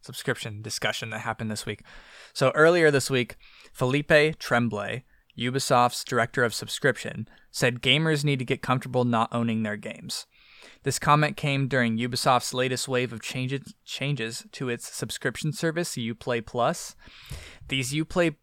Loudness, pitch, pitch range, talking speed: -26 LUFS, 125 Hz, 115-140 Hz, 145 wpm